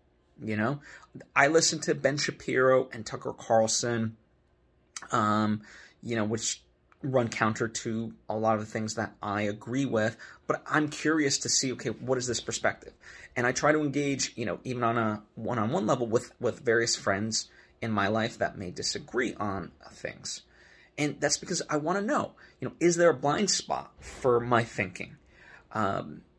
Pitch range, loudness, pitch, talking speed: 110-140 Hz, -29 LUFS, 115 Hz, 175 wpm